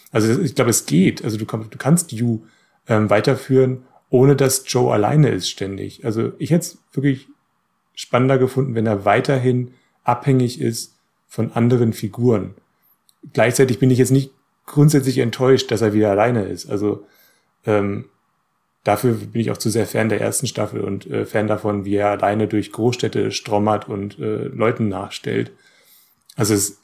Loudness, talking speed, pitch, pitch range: -19 LUFS, 165 wpm, 115 Hz, 105-130 Hz